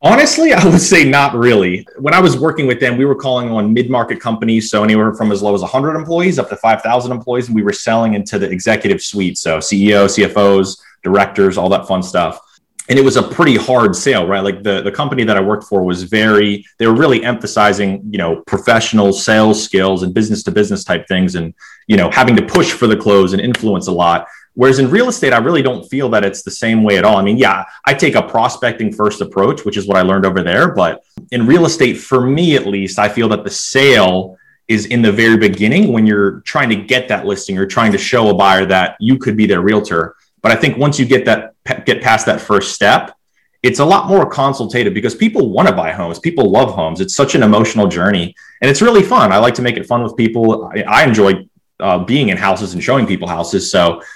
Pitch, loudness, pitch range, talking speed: 110 Hz, -12 LUFS, 100-125 Hz, 235 wpm